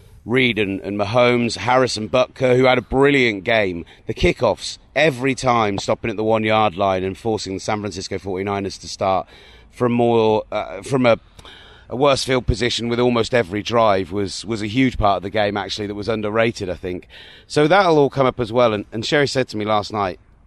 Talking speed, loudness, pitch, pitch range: 210 wpm, -19 LUFS, 110 Hz, 100-125 Hz